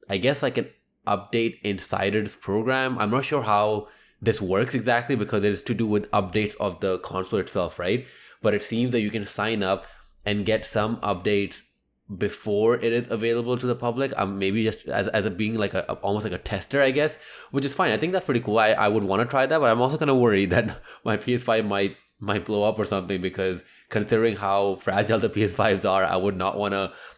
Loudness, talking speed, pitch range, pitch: -24 LUFS, 220 wpm, 100-120 Hz, 105 Hz